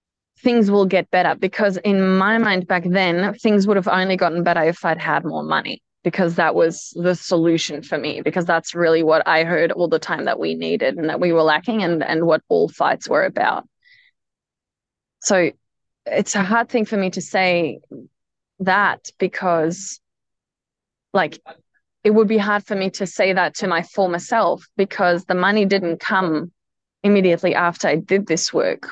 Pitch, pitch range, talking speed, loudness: 185 Hz, 165-200 Hz, 185 wpm, -19 LUFS